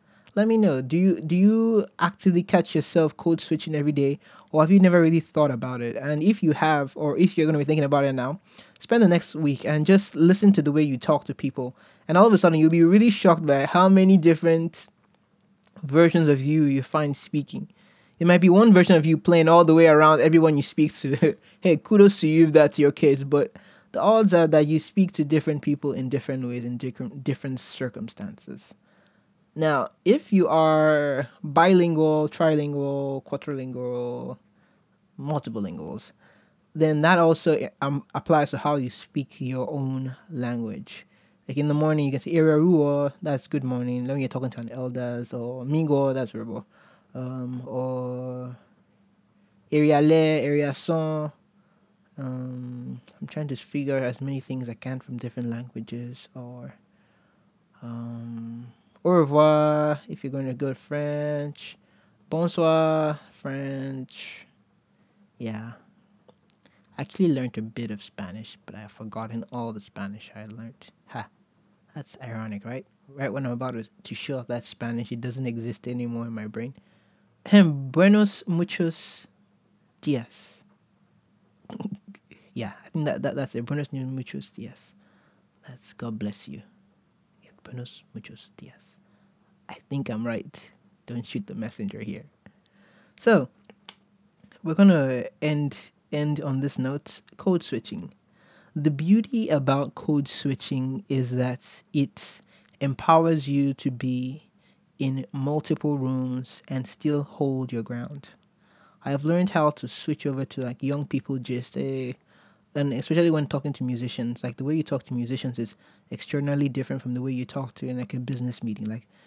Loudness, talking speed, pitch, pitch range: -23 LUFS, 160 wpm, 145 Hz, 125-165 Hz